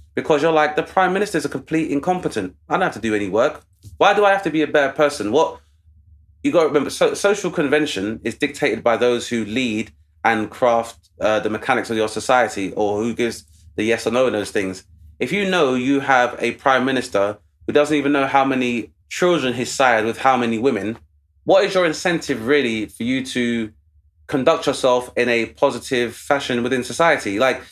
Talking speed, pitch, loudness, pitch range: 210 wpm, 125 Hz, -19 LUFS, 110-145 Hz